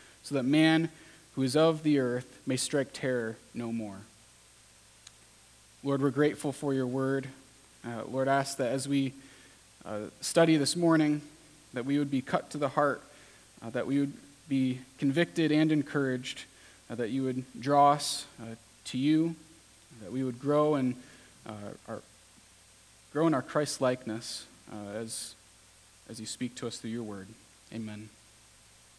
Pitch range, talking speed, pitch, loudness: 115-145 Hz, 155 wpm, 135 Hz, -30 LUFS